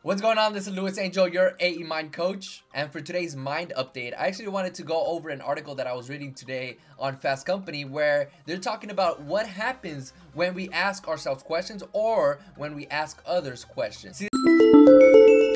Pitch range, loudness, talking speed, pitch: 140-190 Hz, -24 LUFS, 195 wpm, 165 Hz